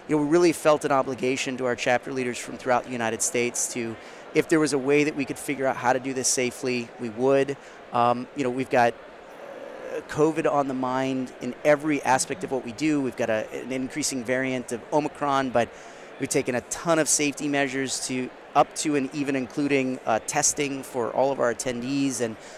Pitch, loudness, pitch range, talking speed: 130 Hz, -25 LUFS, 125-145 Hz, 215 wpm